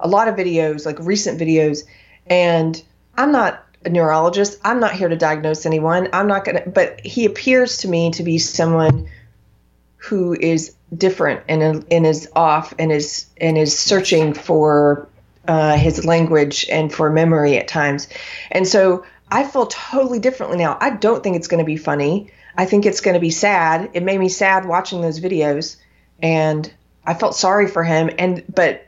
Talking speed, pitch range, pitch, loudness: 180 wpm, 155-185 Hz, 165 Hz, -17 LUFS